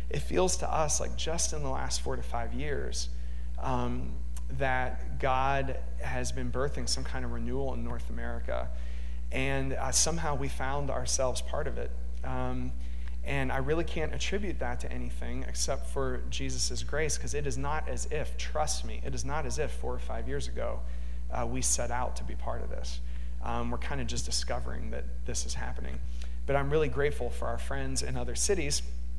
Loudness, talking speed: -33 LUFS, 195 wpm